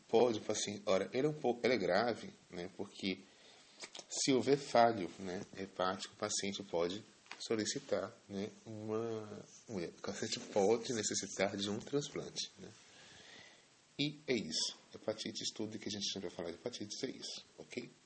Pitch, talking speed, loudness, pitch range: 105 Hz, 155 wpm, -38 LUFS, 95-115 Hz